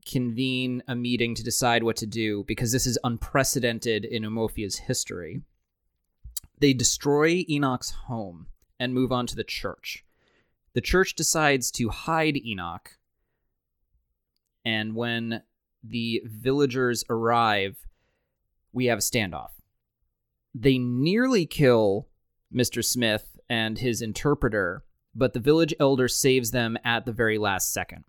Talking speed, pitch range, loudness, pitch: 125 wpm, 110-130 Hz, -25 LUFS, 120 Hz